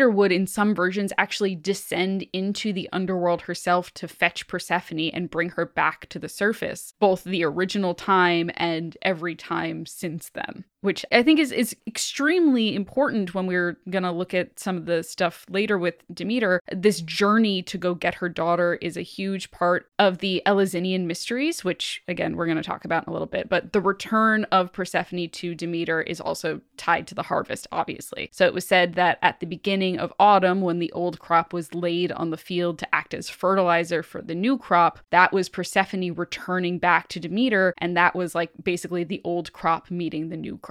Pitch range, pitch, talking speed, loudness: 170-195 Hz, 180 Hz, 195 wpm, -24 LUFS